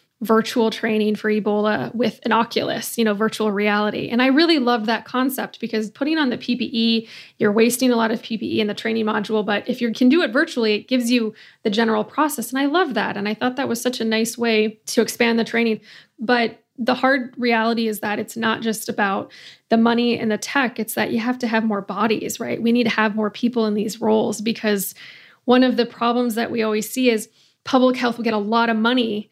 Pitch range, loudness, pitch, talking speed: 215-240 Hz, -20 LUFS, 230 Hz, 230 wpm